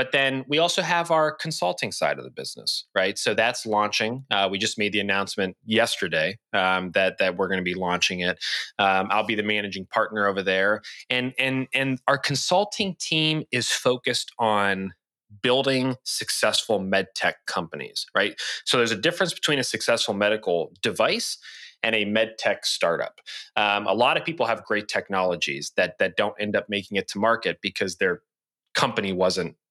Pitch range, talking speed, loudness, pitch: 100-130 Hz, 180 wpm, -24 LUFS, 110 Hz